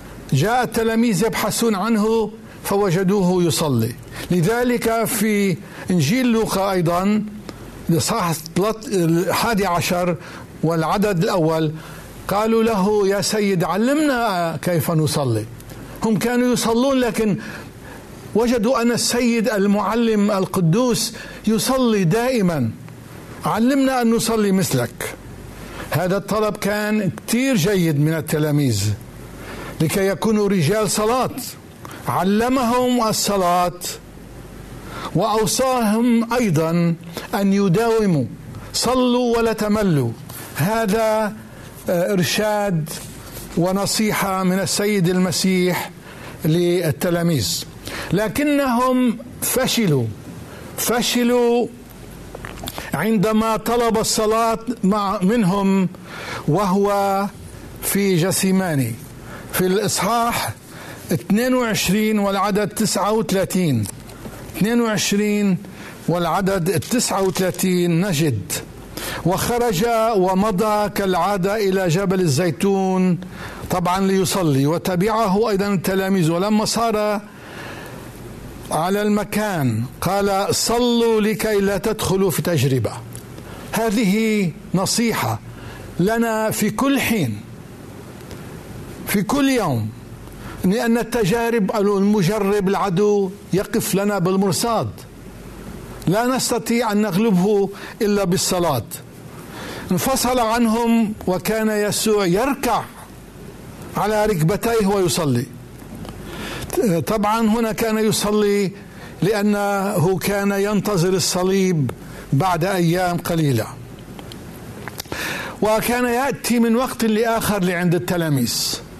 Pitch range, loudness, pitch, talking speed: 175-220 Hz, -19 LUFS, 200 Hz, 75 wpm